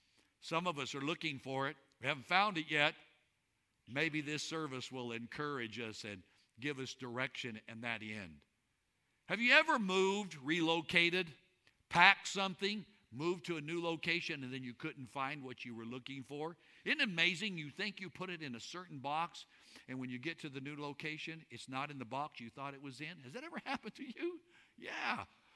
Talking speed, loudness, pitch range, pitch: 195 wpm, -38 LUFS, 130-175 Hz, 150 Hz